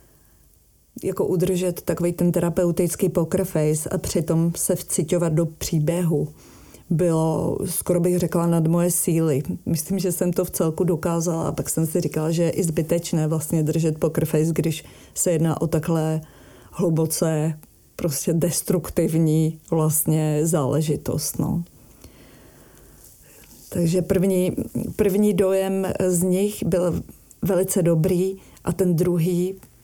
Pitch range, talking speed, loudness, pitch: 160-180 Hz, 125 wpm, -22 LUFS, 170 Hz